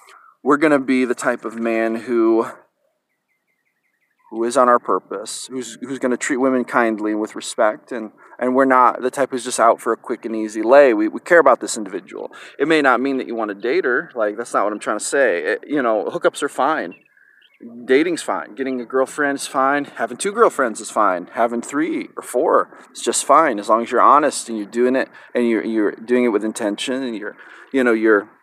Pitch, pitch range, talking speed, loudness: 125 Hz, 115-145 Hz, 225 wpm, -18 LUFS